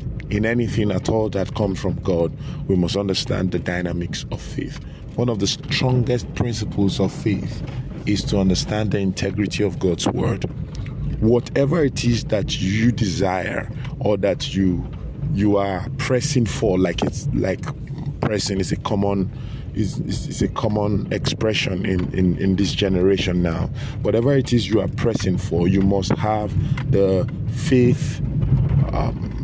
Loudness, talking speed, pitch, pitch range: -21 LUFS, 155 wpm, 110 Hz, 95-130 Hz